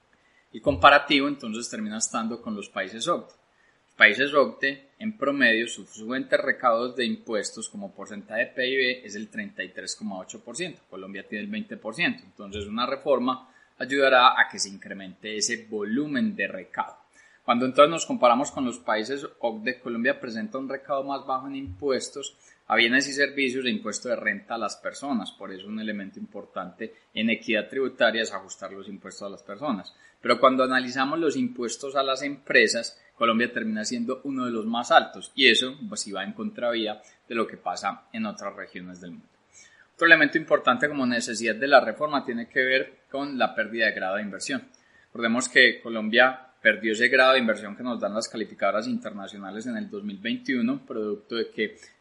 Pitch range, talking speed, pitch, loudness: 110-145 Hz, 175 wpm, 130 Hz, -24 LUFS